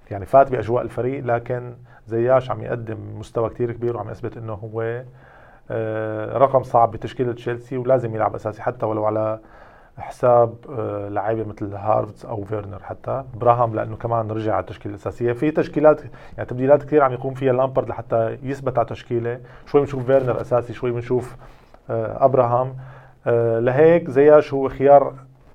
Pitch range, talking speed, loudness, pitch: 110-130 Hz, 150 wpm, -20 LUFS, 120 Hz